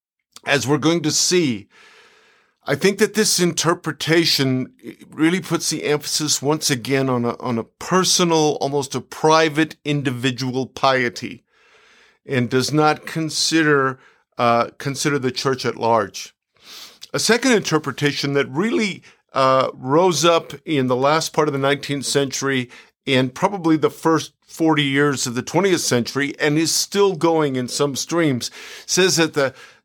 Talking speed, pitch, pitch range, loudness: 145 wpm, 150 Hz, 135-165 Hz, -19 LUFS